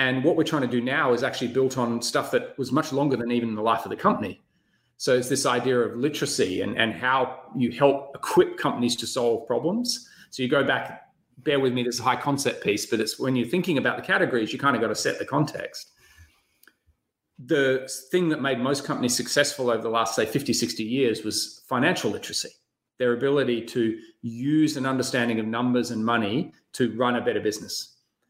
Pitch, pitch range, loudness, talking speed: 125 Hz, 120-140 Hz, -25 LUFS, 210 wpm